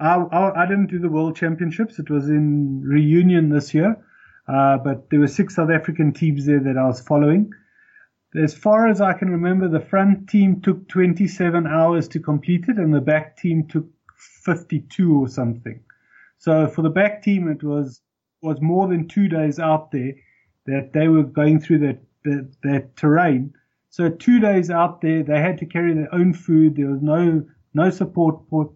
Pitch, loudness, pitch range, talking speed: 160 Hz, -19 LUFS, 145-180 Hz, 190 wpm